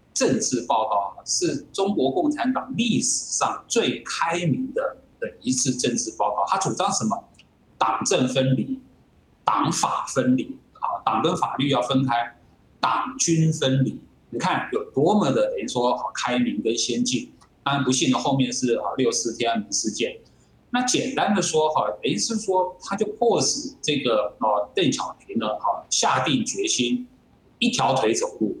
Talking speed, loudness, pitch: 230 characters per minute, -23 LUFS, 180 Hz